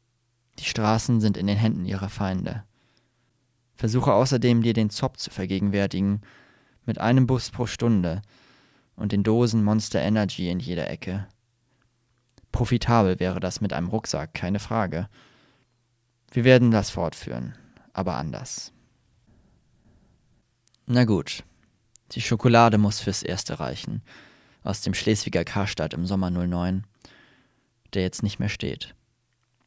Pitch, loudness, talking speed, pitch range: 110 Hz, -24 LUFS, 125 wpm, 100-120 Hz